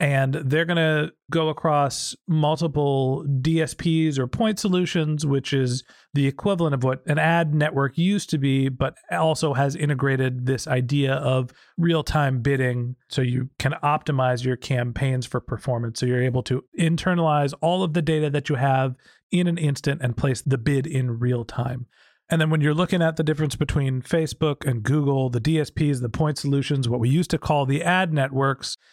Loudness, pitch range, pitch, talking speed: -23 LUFS, 130-160 Hz, 140 Hz, 180 wpm